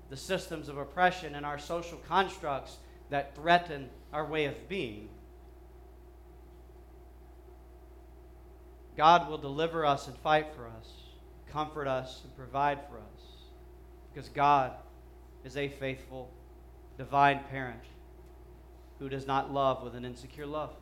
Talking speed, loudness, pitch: 125 wpm, -31 LUFS, 135 Hz